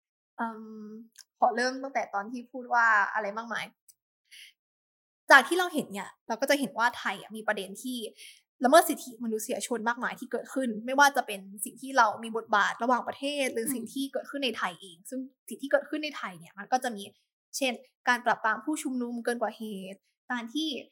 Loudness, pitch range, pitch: -28 LUFS, 220-265 Hz, 240 Hz